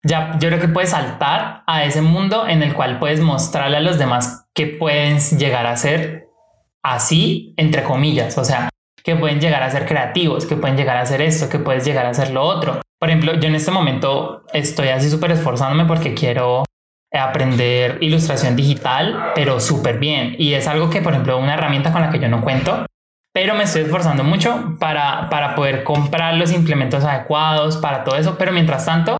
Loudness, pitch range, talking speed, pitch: -17 LUFS, 140-165 Hz, 195 wpm, 150 Hz